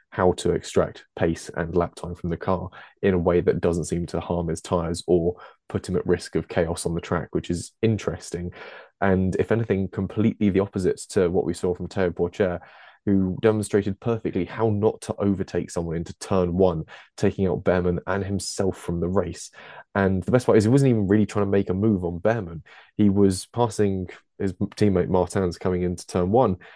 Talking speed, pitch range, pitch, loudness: 205 wpm, 90-100 Hz, 95 Hz, -24 LUFS